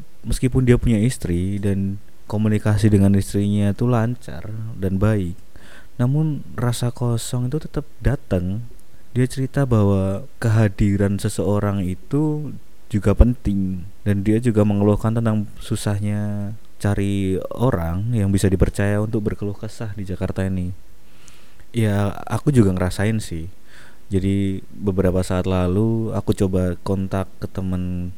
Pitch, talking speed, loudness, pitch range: 105 Hz, 120 wpm, -21 LUFS, 95-115 Hz